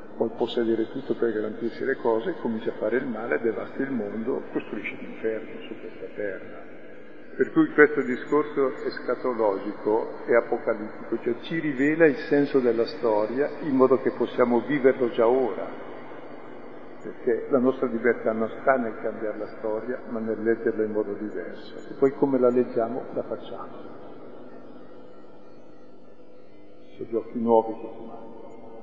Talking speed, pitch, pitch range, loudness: 145 wpm, 120 Hz, 115-145 Hz, -25 LUFS